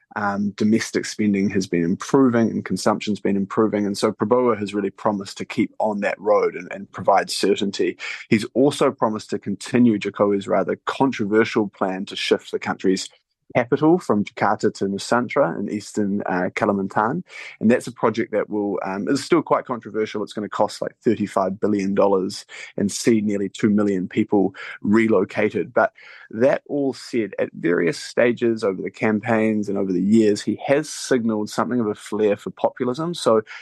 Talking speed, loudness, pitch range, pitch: 175 wpm, -21 LUFS, 100-120 Hz, 110 Hz